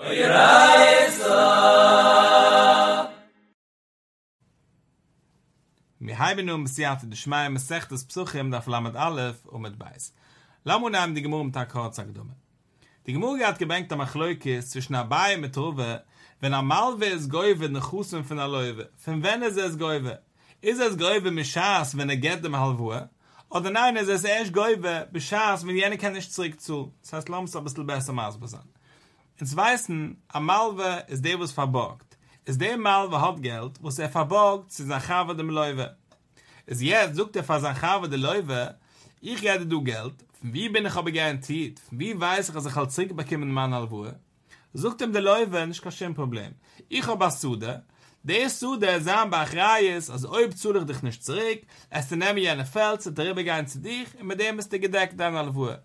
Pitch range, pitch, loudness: 135-190 Hz, 155 Hz, -24 LUFS